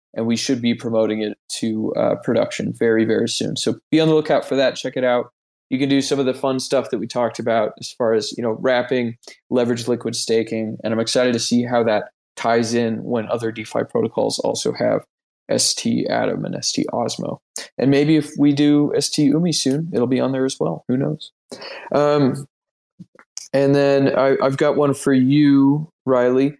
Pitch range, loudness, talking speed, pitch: 115-140 Hz, -19 LUFS, 200 wpm, 130 Hz